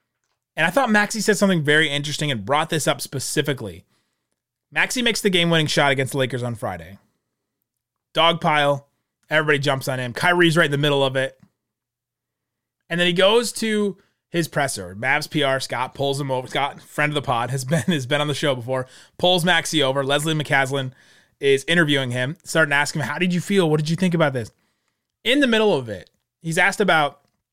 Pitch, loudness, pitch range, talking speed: 145 Hz, -20 LUFS, 130-170 Hz, 200 wpm